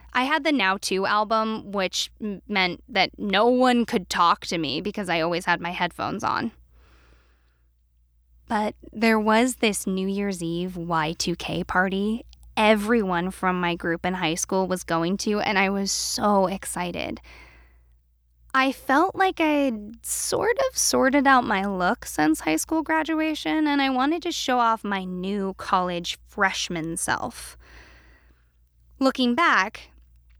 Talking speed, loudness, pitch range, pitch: 145 wpm, -23 LUFS, 165-235 Hz, 190 Hz